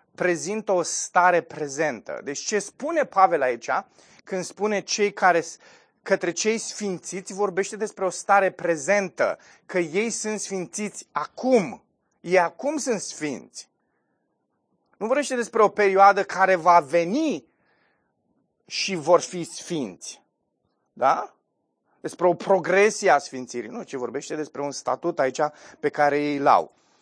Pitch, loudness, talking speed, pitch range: 190 Hz, -23 LUFS, 135 wpm, 170-210 Hz